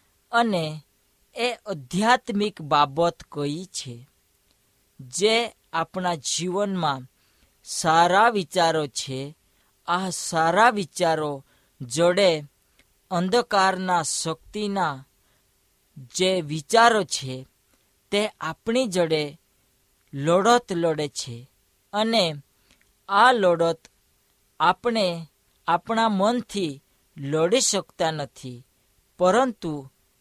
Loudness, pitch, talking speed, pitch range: -23 LUFS, 165 Hz, 75 wpm, 140-195 Hz